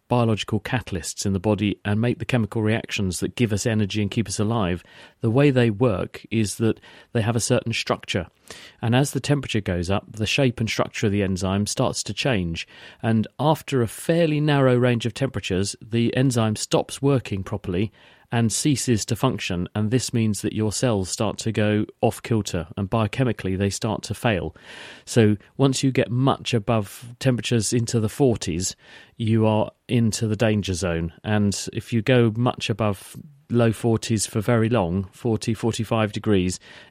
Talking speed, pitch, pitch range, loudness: 175 wpm, 115 Hz, 105-125 Hz, -23 LUFS